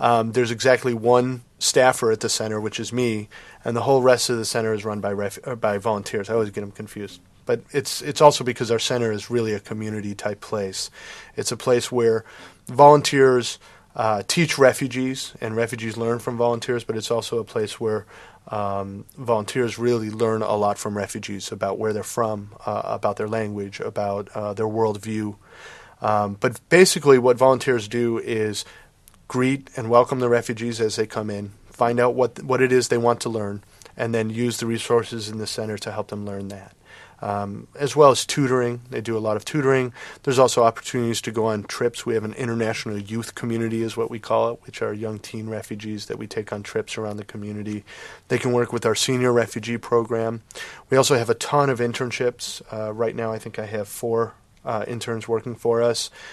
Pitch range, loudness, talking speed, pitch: 105-120 Hz, -22 LUFS, 205 wpm, 115 Hz